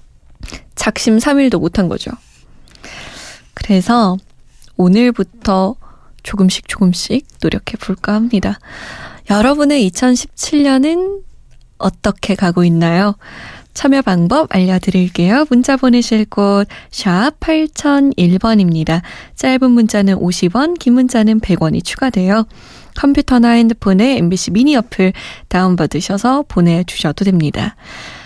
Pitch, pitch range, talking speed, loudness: 210 Hz, 185-255 Hz, 230 characters per minute, -13 LUFS